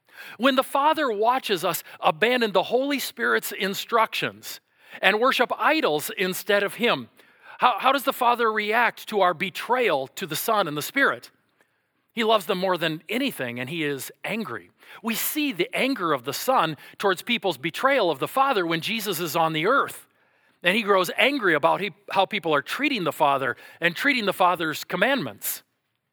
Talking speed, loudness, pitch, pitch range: 175 wpm, -23 LUFS, 205 Hz, 180-240 Hz